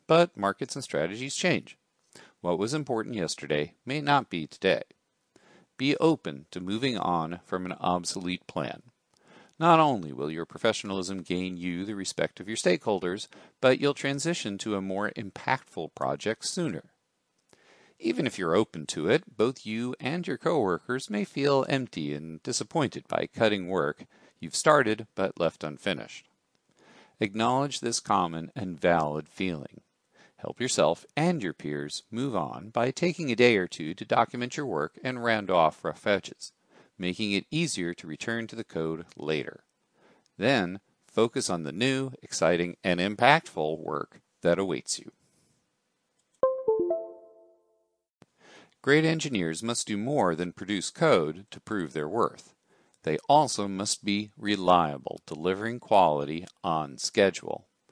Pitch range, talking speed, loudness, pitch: 90-130 Hz, 140 wpm, -28 LUFS, 110 Hz